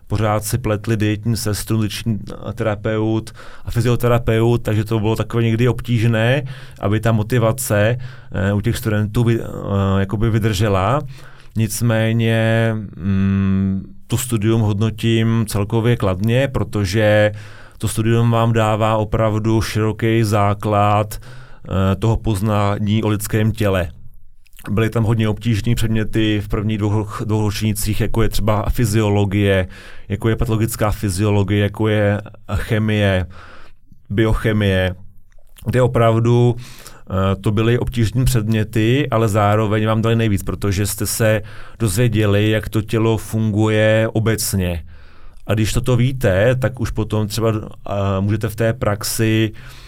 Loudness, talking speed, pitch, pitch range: -18 LUFS, 125 wpm, 110 Hz, 105-115 Hz